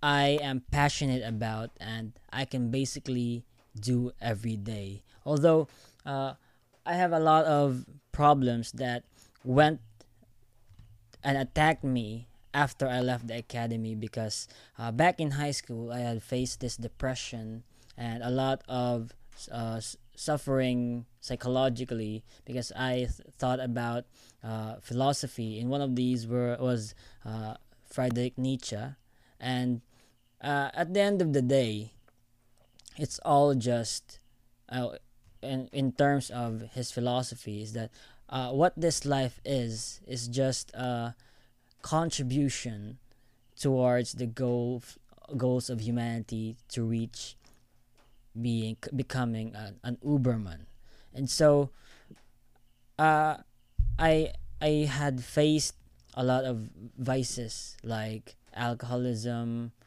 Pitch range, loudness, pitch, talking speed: 115-135 Hz, -30 LUFS, 125 Hz, 120 wpm